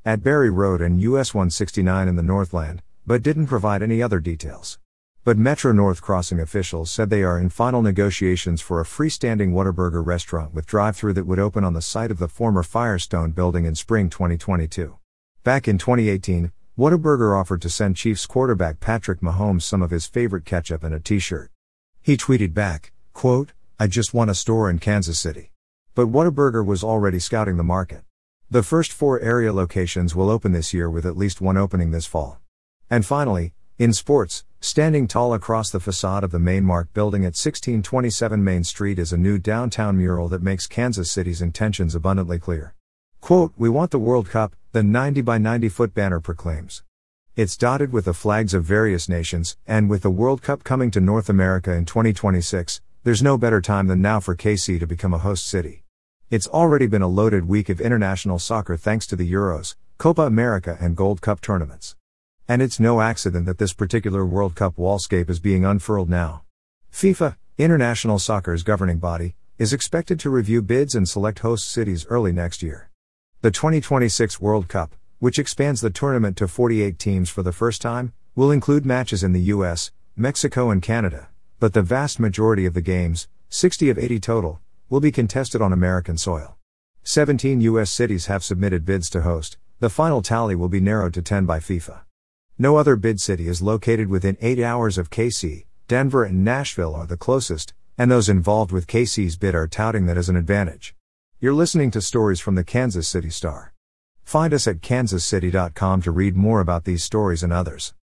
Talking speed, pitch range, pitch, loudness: 185 wpm, 90-115 Hz, 100 Hz, -21 LUFS